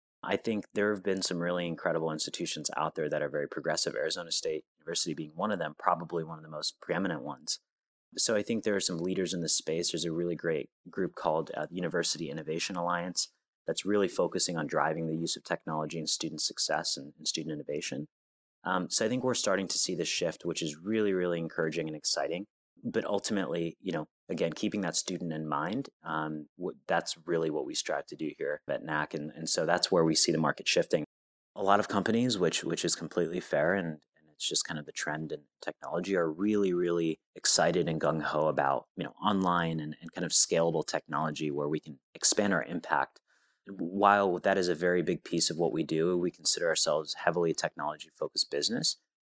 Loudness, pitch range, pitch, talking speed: -31 LUFS, 80-100 Hz, 85 Hz, 215 wpm